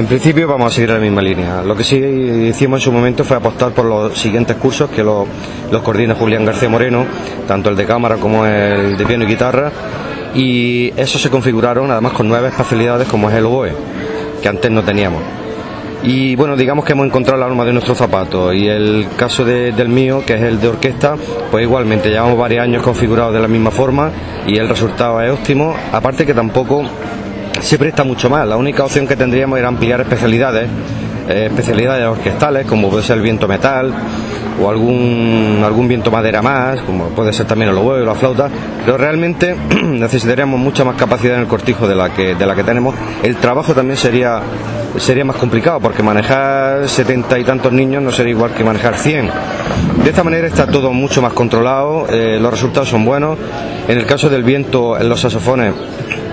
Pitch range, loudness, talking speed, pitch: 110-130 Hz, -13 LUFS, 200 wpm, 120 Hz